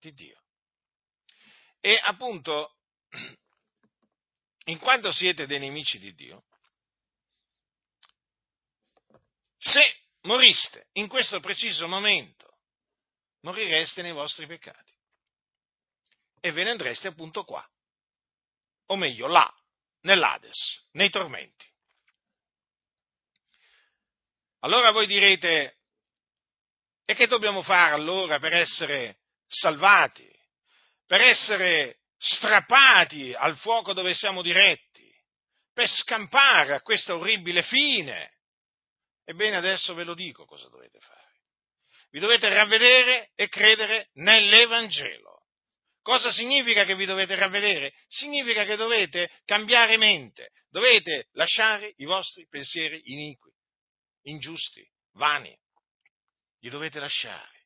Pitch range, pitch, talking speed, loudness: 175-230 Hz, 205 Hz, 95 wpm, -20 LUFS